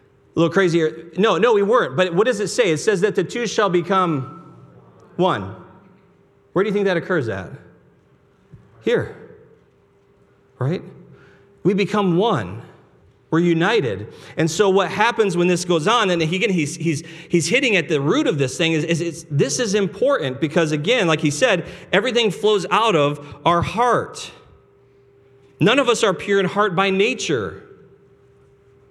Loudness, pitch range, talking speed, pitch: -19 LUFS, 150-195 Hz, 170 wpm, 170 Hz